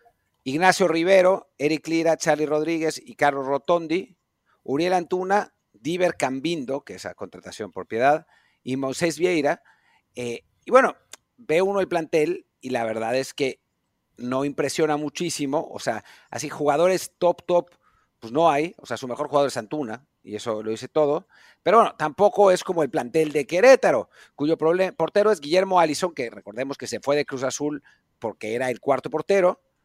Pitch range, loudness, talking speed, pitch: 135-180 Hz, -23 LUFS, 170 wpm, 155 Hz